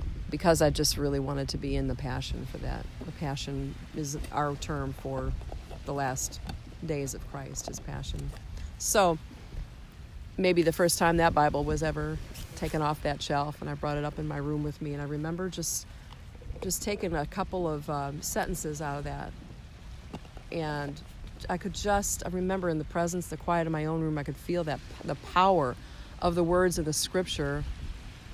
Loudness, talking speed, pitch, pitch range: -31 LUFS, 190 wpm, 150 Hz, 140-165 Hz